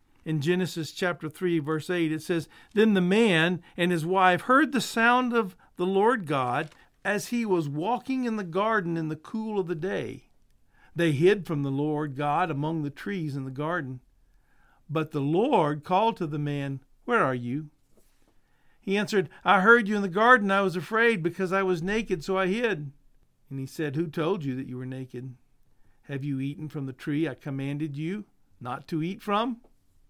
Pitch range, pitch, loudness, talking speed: 145-195 Hz, 165 Hz, -26 LUFS, 195 wpm